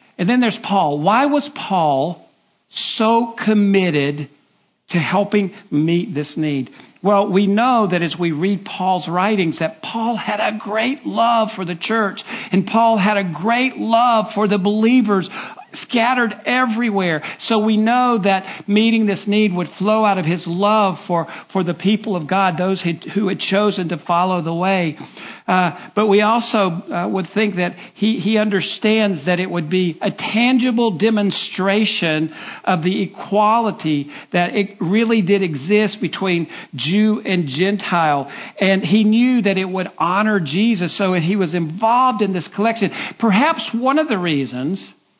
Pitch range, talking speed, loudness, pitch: 180-220 Hz, 160 wpm, -17 LUFS, 200 Hz